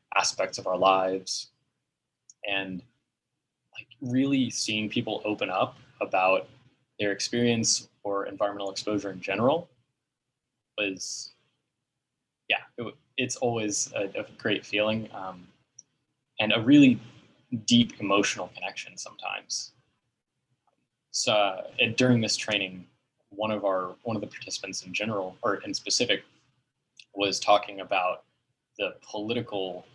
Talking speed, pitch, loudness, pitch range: 120 wpm, 105 Hz, -27 LUFS, 100-120 Hz